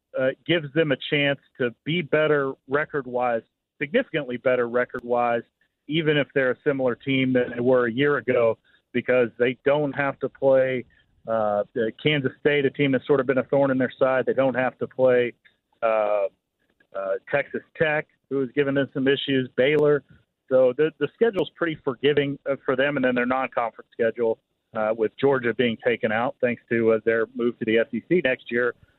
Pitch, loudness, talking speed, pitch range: 130 Hz, -23 LUFS, 185 wpm, 120-145 Hz